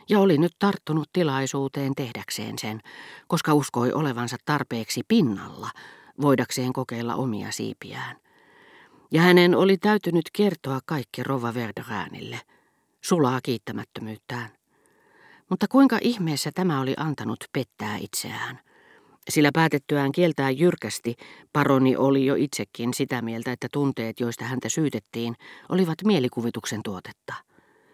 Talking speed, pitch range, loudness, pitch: 110 wpm, 120-175 Hz, -24 LUFS, 140 Hz